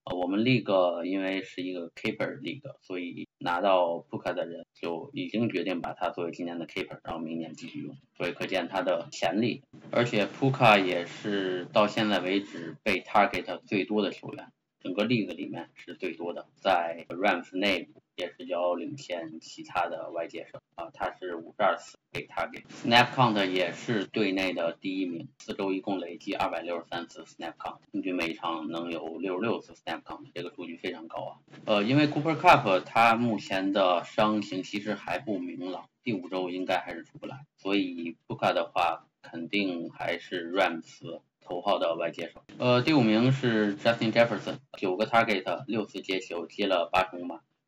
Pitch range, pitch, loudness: 85-115 Hz, 95 Hz, -29 LUFS